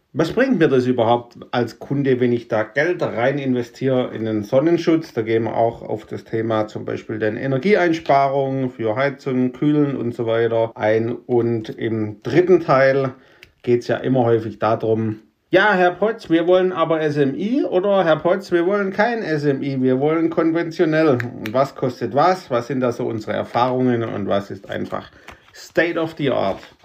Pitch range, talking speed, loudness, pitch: 115-160 Hz, 175 wpm, -19 LUFS, 130 Hz